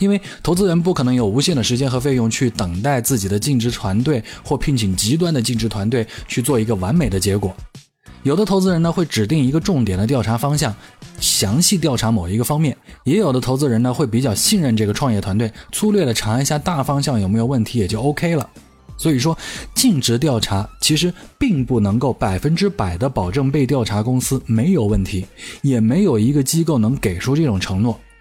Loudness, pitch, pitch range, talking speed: -18 LUFS, 125 Hz, 110-150 Hz, 325 characters per minute